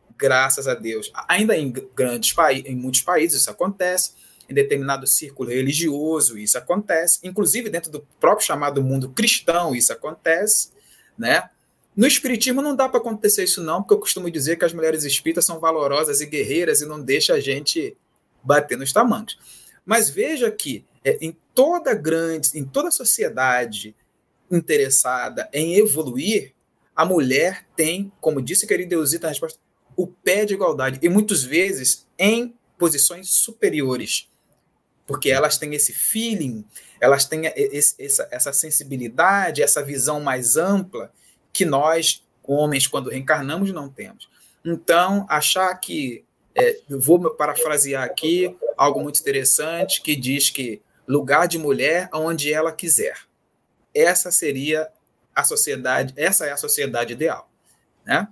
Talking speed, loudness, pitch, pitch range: 140 wpm, -19 LUFS, 160 Hz, 140-200 Hz